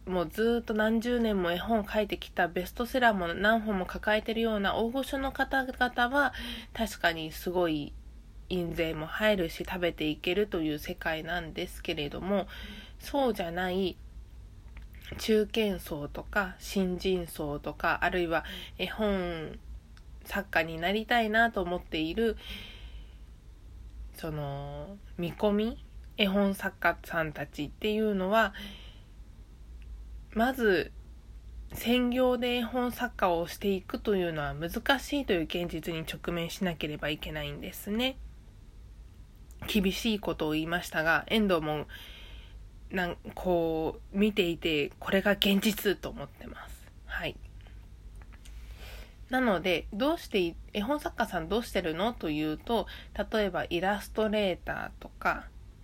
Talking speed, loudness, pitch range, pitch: 260 characters per minute, -30 LUFS, 155-215 Hz, 180 Hz